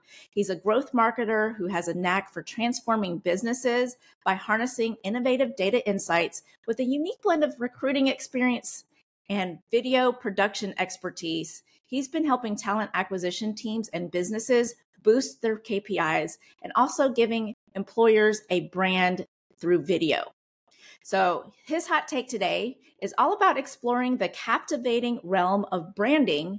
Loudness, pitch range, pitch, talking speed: -26 LUFS, 190-250 Hz, 220 Hz, 135 wpm